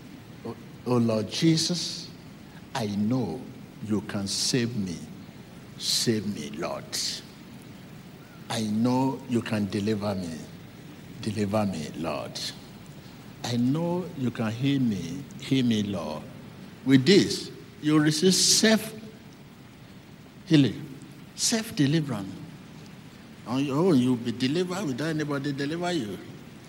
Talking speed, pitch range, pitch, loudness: 105 wpm, 110-160 Hz, 130 Hz, -26 LUFS